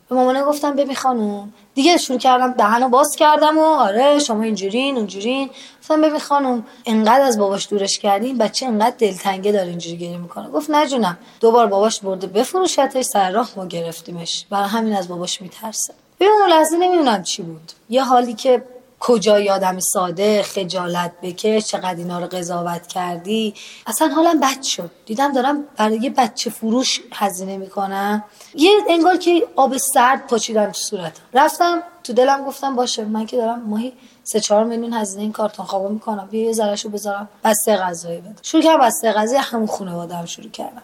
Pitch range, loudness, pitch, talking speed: 200-265 Hz, -18 LUFS, 225 Hz, 175 wpm